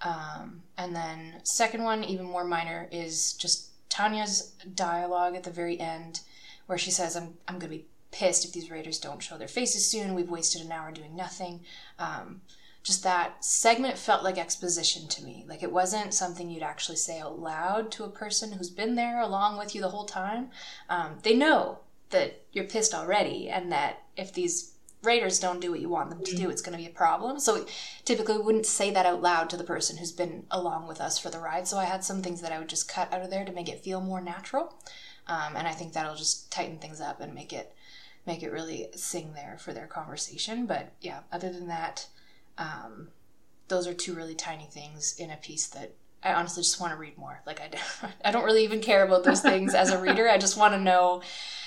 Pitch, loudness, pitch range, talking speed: 180 Hz, -29 LUFS, 165-205 Hz, 225 wpm